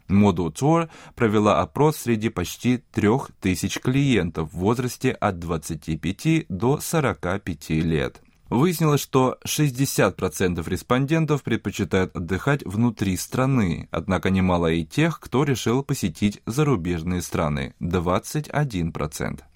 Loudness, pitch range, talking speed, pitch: -23 LUFS, 90-135 Hz, 100 wpm, 105 Hz